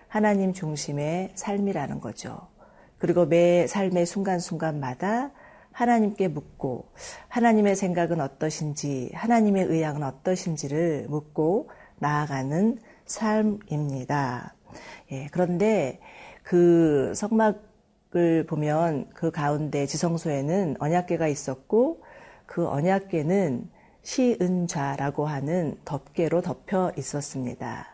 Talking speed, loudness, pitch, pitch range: 240 characters per minute, -26 LUFS, 170 Hz, 150-195 Hz